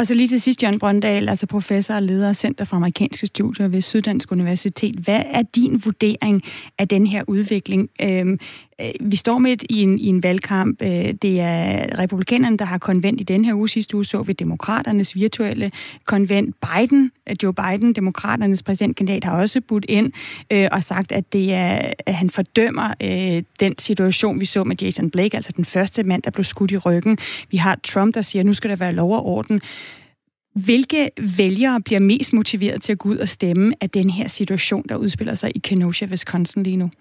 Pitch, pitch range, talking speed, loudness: 200 Hz, 190-220 Hz, 195 wpm, -19 LUFS